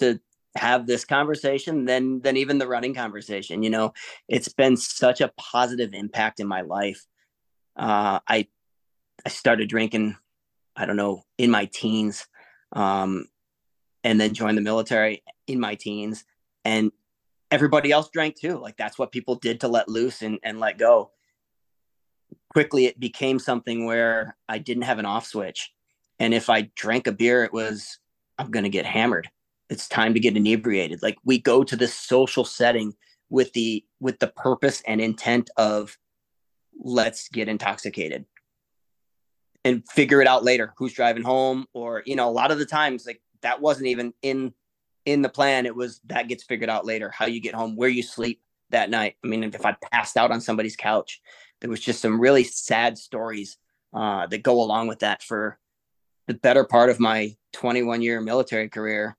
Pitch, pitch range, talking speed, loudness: 115 Hz, 110-130 Hz, 180 wpm, -23 LUFS